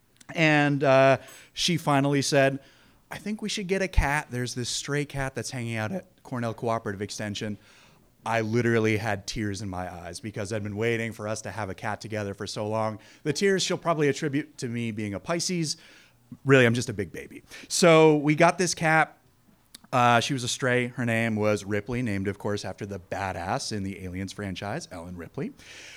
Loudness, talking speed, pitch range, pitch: -26 LUFS, 200 wpm, 105-145 Hz, 120 Hz